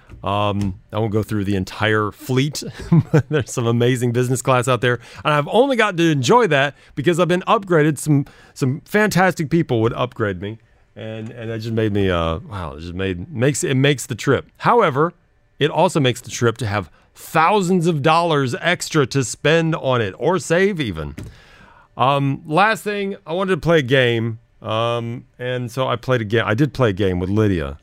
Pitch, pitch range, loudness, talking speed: 125 Hz, 110-155 Hz, -19 LUFS, 195 wpm